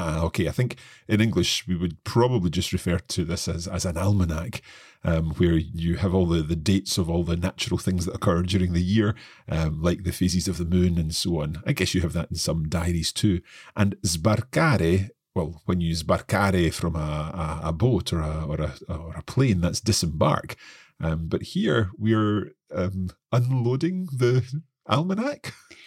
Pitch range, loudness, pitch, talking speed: 85-105 Hz, -25 LUFS, 90 Hz, 190 wpm